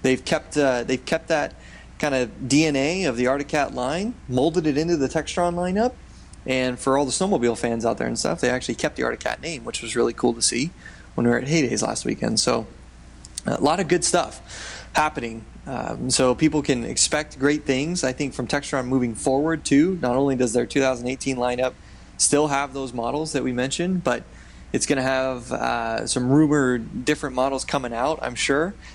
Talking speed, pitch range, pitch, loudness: 200 wpm, 125-150 Hz, 135 Hz, -23 LUFS